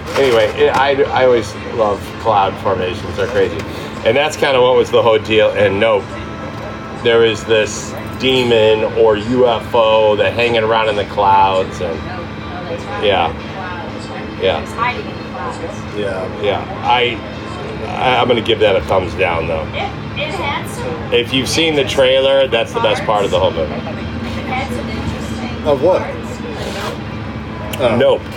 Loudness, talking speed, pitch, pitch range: -15 LUFS, 130 wpm, 110 Hz, 105-140 Hz